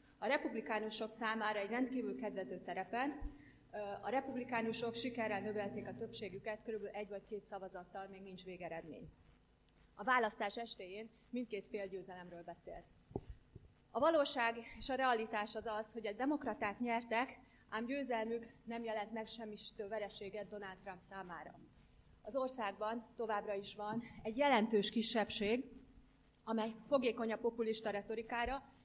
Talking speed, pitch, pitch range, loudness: 130 wpm, 220 Hz, 205-235 Hz, -41 LUFS